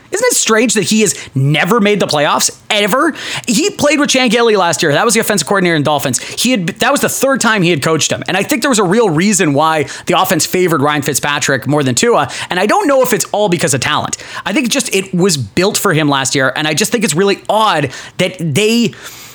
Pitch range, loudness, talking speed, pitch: 150-225 Hz, -12 LUFS, 255 wpm, 195 Hz